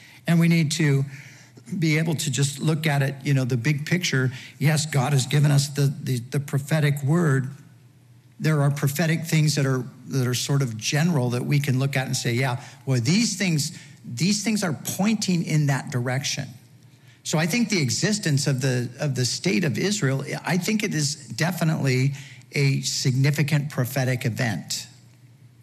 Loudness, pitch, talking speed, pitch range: -23 LUFS, 140 Hz, 180 wpm, 130-155 Hz